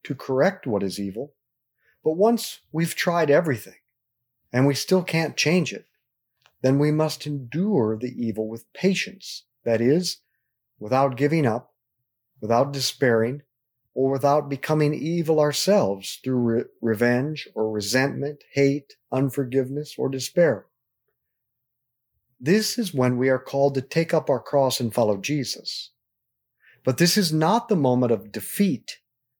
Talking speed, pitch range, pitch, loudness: 135 wpm, 125-155 Hz, 135 Hz, -23 LUFS